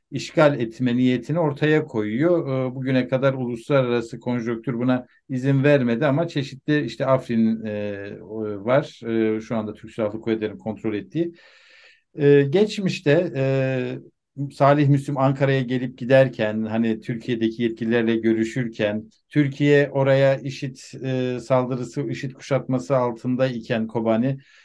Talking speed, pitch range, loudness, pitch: 105 wpm, 115-140 Hz, -22 LUFS, 130 Hz